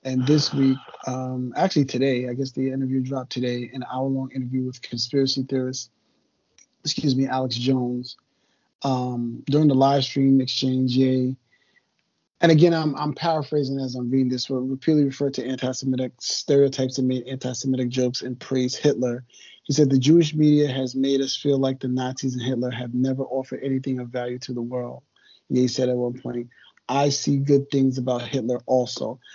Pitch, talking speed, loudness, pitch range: 130 Hz, 175 wpm, -23 LUFS, 125-135 Hz